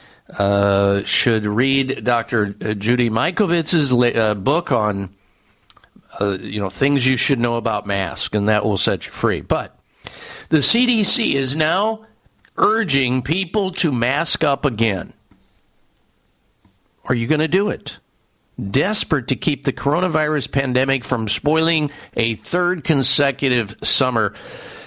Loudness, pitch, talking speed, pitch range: -18 LUFS, 135 Hz, 130 wpm, 110-155 Hz